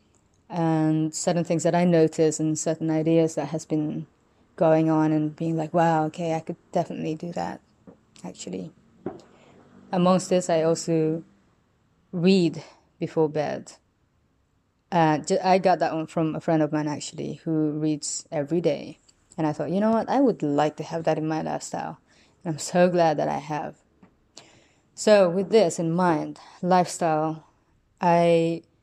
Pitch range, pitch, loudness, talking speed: 155-175 Hz, 160 Hz, -24 LUFS, 160 wpm